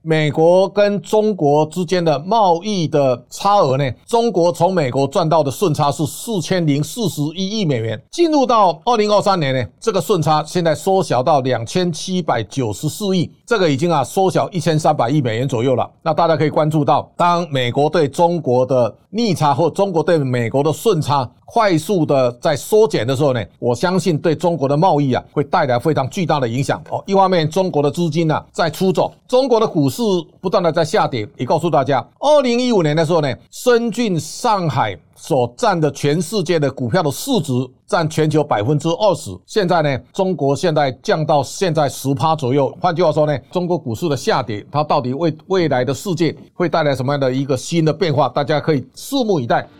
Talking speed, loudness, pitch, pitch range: 305 characters per minute, -17 LUFS, 160 Hz, 140-185 Hz